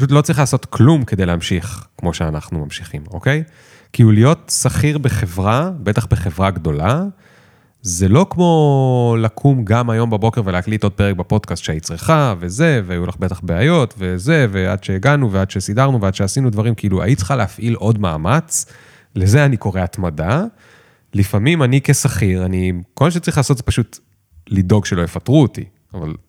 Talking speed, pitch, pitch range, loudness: 160 wpm, 110 Hz, 95-135 Hz, -16 LUFS